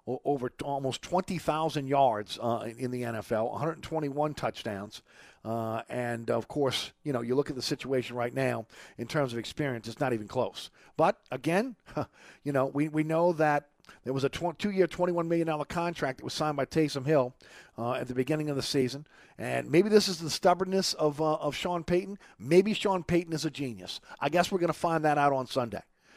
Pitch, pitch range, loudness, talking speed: 145 Hz, 125-170 Hz, -30 LUFS, 205 wpm